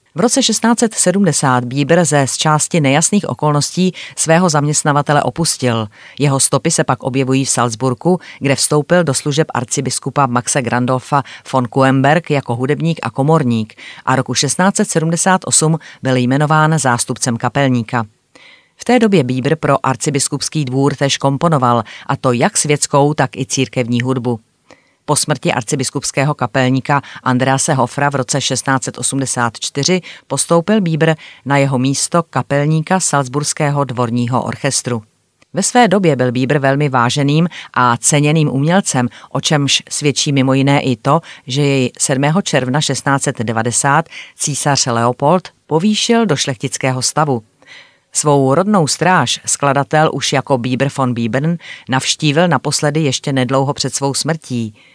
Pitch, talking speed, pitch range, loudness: 140 Hz, 130 wpm, 130-155 Hz, -14 LUFS